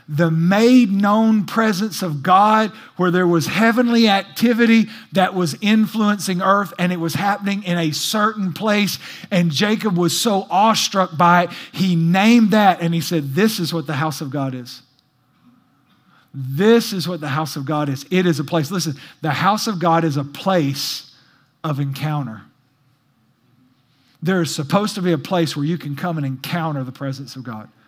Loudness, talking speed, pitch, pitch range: -18 LUFS, 180 wpm, 175 Hz, 145-200 Hz